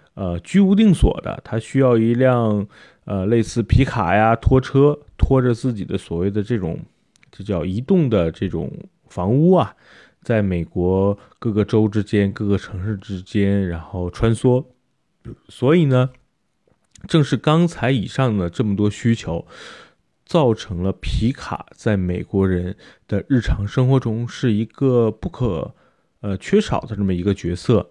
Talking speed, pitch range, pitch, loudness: 220 characters per minute, 95-130 Hz, 110 Hz, -19 LUFS